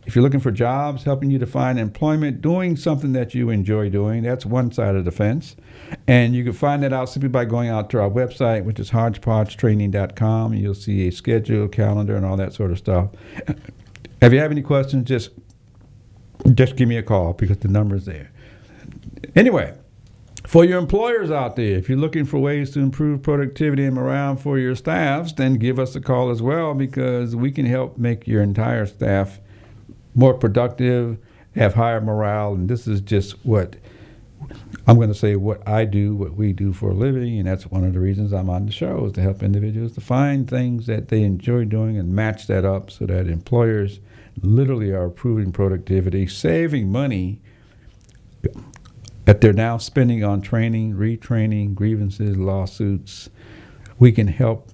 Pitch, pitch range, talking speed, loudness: 110 Hz, 100-125 Hz, 185 wpm, -20 LUFS